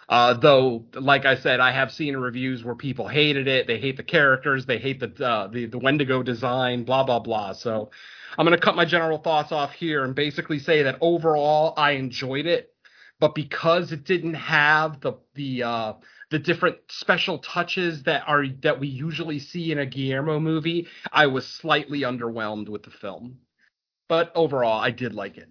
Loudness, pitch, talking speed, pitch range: -23 LUFS, 145 Hz, 190 wpm, 125-160 Hz